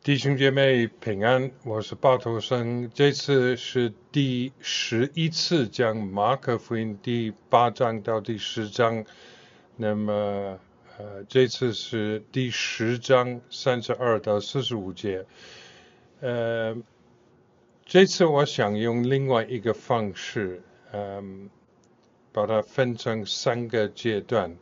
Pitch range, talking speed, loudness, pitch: 110-130 Hz, 170 characters per minute, -25 LUFS, 120 Hz